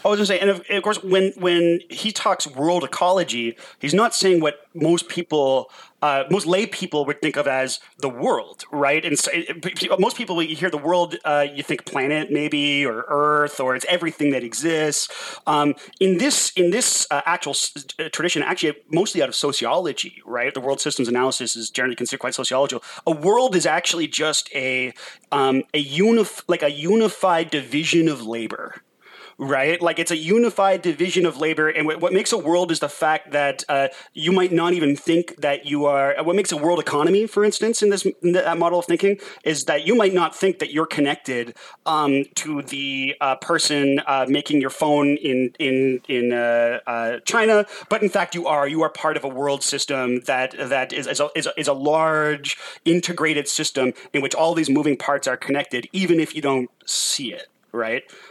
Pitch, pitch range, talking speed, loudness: 155 Hz, 140-175 Hz, 200 wpm, -21 LUFS